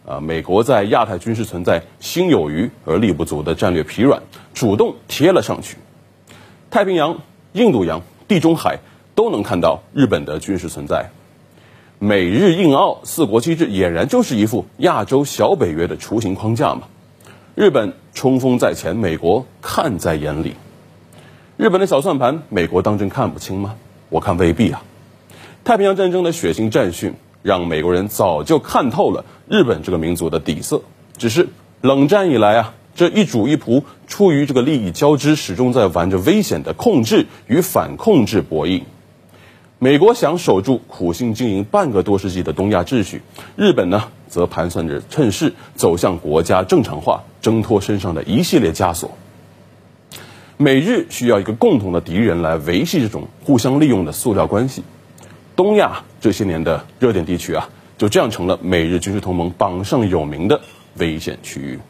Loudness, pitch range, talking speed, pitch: -17 LUFS, 85-130 Hz, 260 characters per minute, 100 Hz